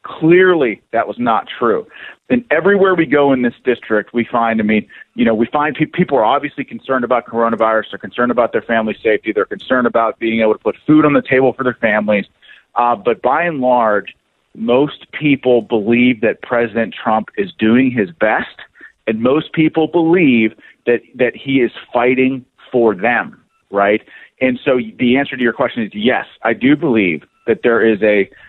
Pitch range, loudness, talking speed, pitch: 115-145 Hz, -15 LUFS, 185 wpm, 125 Hz